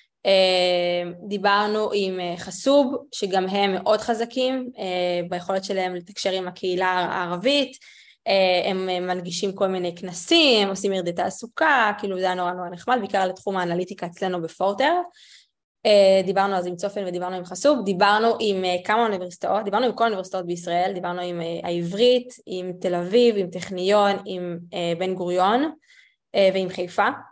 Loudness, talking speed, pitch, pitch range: -22 LUFS, 135 wpm, 190 Hz, 180-215 Hz